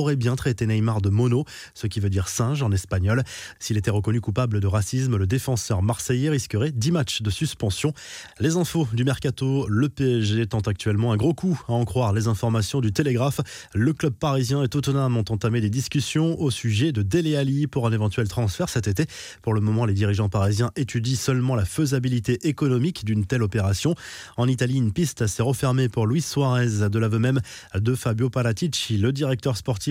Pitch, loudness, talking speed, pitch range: 120 Hz, -23 LUFS, 195 wpm, 110-140 Hz